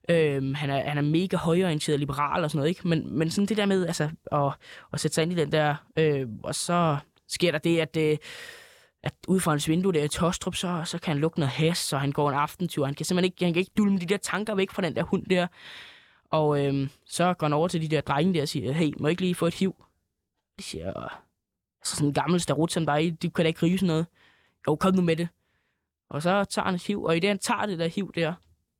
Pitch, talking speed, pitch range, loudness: 165 Hz, 265 wpm, 145-180 Hz, -26 LUFS